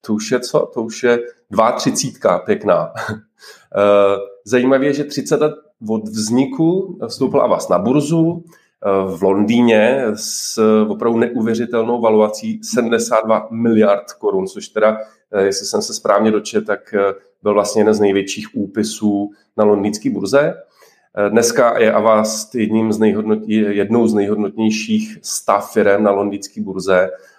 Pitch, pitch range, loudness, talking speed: 110 Hz, 100-120 Hz, -16 LUFS, 130 wpm